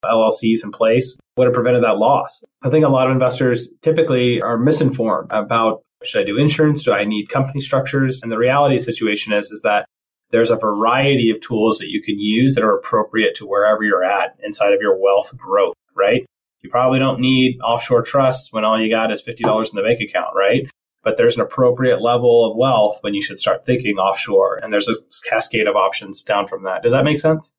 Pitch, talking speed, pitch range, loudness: 125 Hz, 220 wpm, 115-150 Hz, -17 LUFS